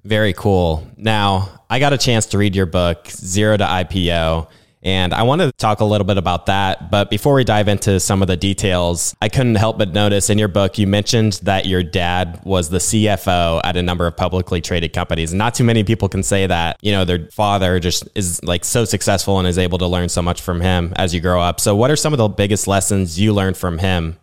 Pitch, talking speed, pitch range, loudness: 95 Hz, 240 wpm, 90-105 Hz, -16 LUFS